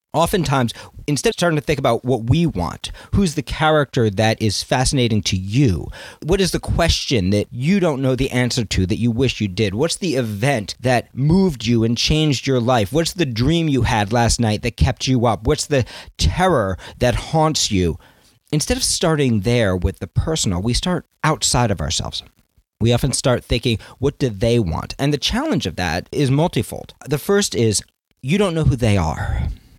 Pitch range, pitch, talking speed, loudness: 110-150 Hz, 125 Hz, 195 wpm, -19 LUFS